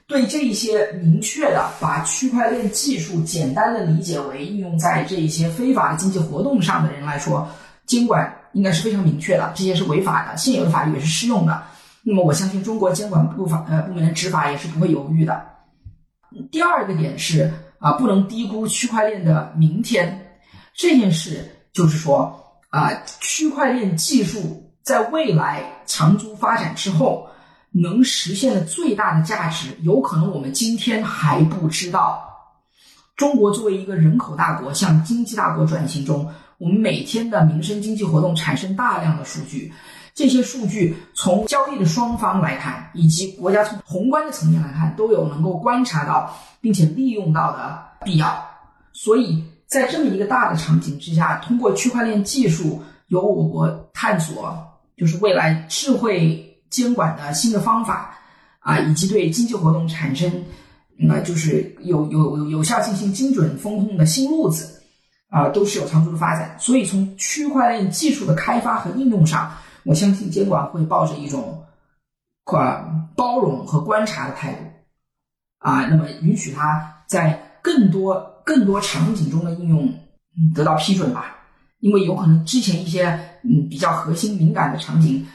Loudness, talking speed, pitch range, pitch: -19 LUFS, 260 characters per minute, 160-220 Hz, 180 Hz